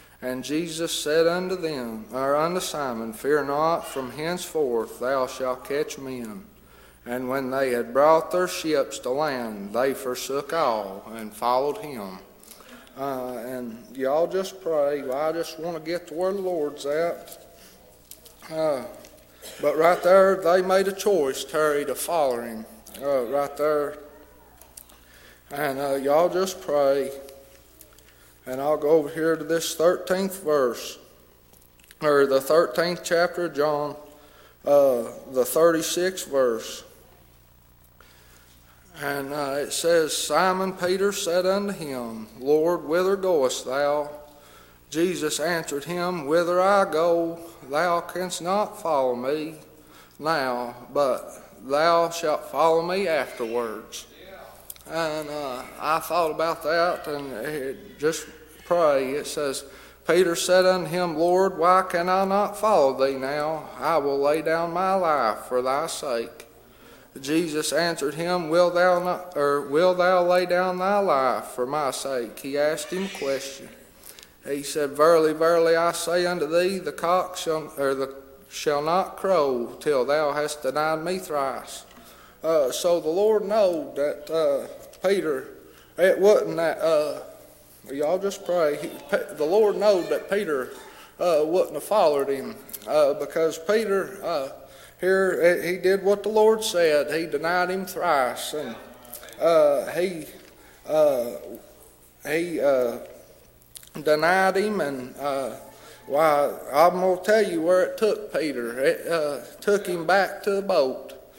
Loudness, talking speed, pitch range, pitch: -24 LUFS, 140 wpm, 135-180 Hz, 160 Hz